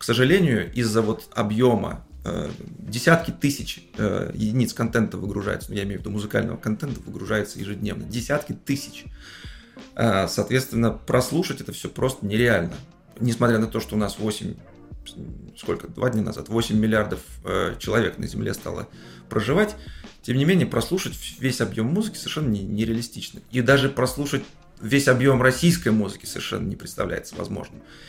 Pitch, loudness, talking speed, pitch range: 115 Hz, -24 LUFS, 150 wpm, 105-135 Hz